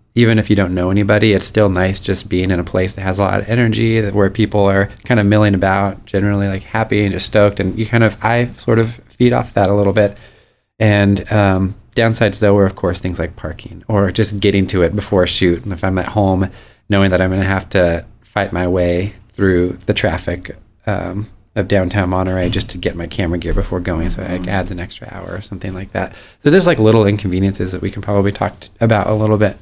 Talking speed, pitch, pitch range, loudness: 245 wpm, 100 Hz, 95-105 Hz, -15 LUFS